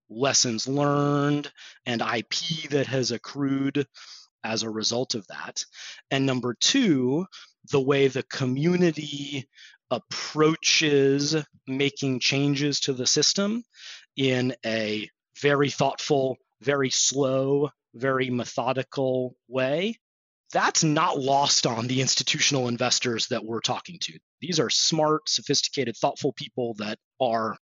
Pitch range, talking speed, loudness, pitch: 125-145 Hz, 115 wpm, -25 LUFS, 135 Hz